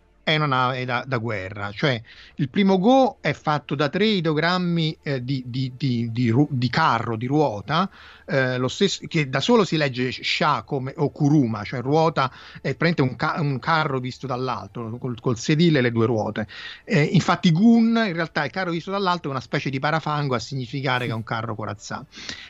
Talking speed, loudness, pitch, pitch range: 200 wpm, -22 LUFS, 140 Hz, 125-160 Hz